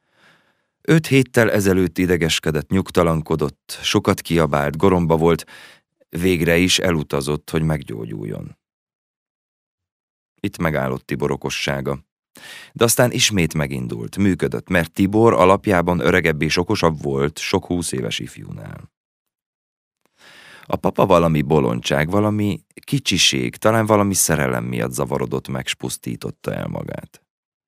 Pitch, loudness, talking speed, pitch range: 85 Hz, -19 LUFS, 105 wpm, 75-95 Hz